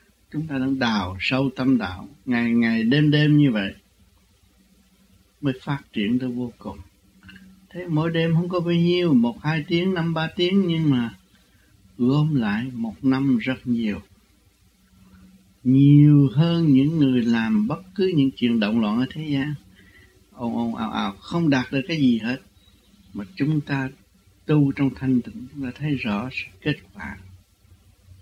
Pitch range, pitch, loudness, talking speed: 100-150 Hz, 130 Hz, -22 LUFS, 165 wpm